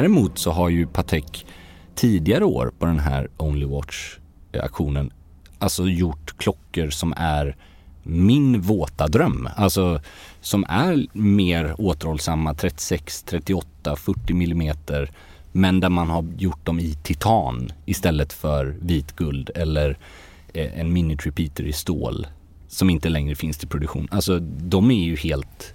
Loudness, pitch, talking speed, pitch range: -22 LUFS, 80 Hz, 135 wpm, 75-90 Hz